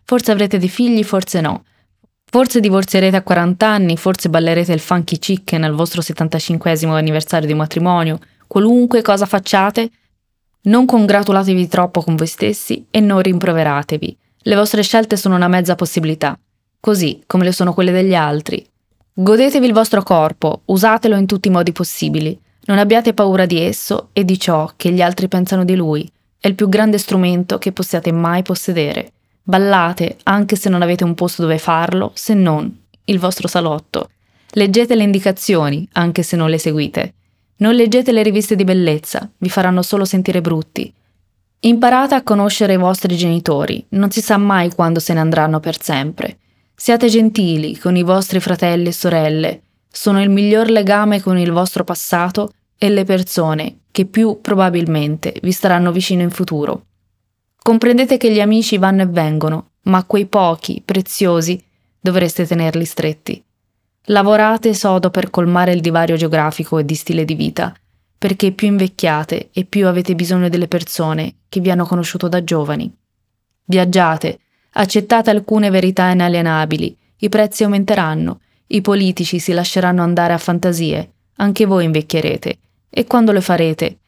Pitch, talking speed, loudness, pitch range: 180 Hz, 155 wpm, -14 LUFS, 165-205 Hz